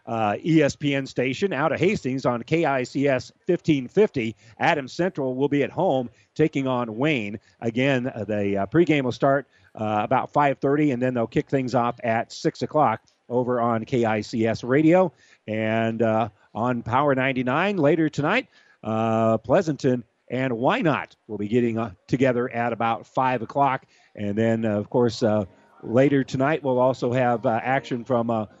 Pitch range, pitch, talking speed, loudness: 115-140 Hz, 125 Hz, 160 wpm, -23 LUFS